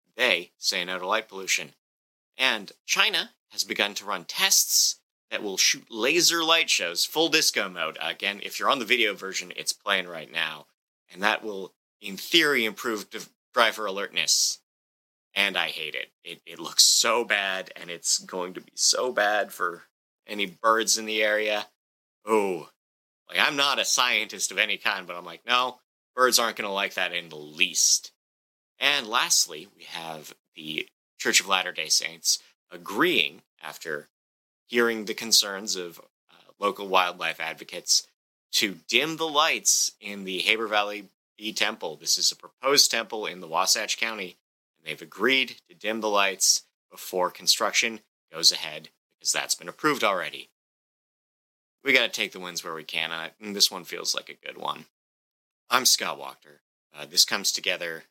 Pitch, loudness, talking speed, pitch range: 105 Hz, -24 LUFS, 170 wpm, 85-115 Hz